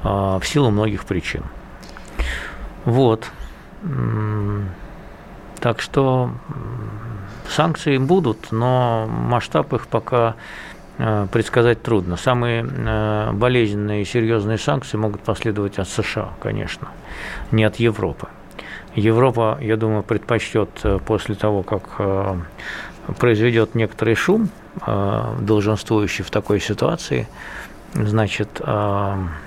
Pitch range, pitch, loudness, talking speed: 105-115 Hz, 110 Hz, -20 LUFS, 90 wpm